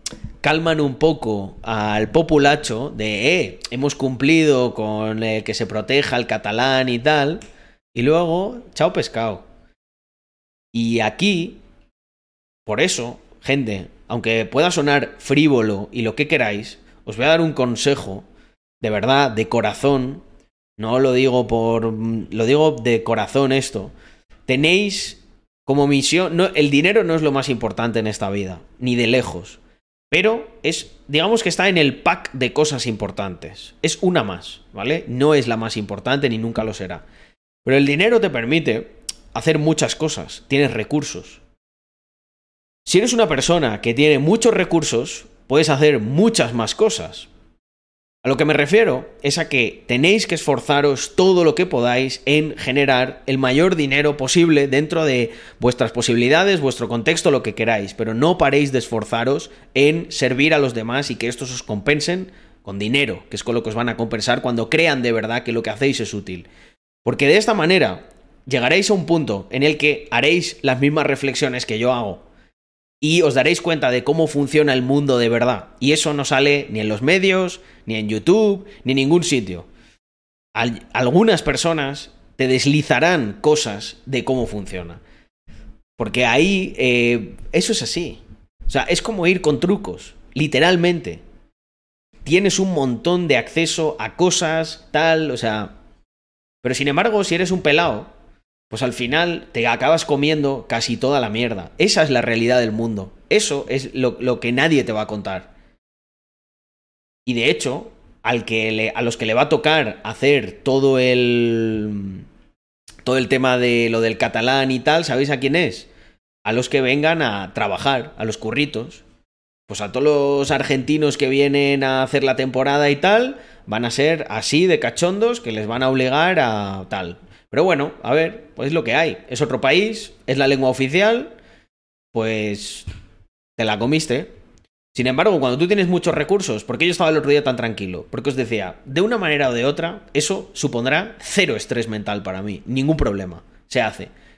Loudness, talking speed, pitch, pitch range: -18 LUFS, 170 wpm, 130 Hz, 115-155 Hz